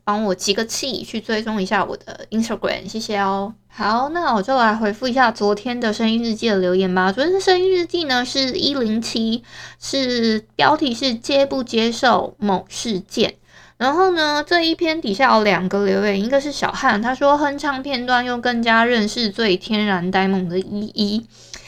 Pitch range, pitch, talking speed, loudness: 205-265 Hz, 225 Hz, 285 characters per minute, -19 LUFS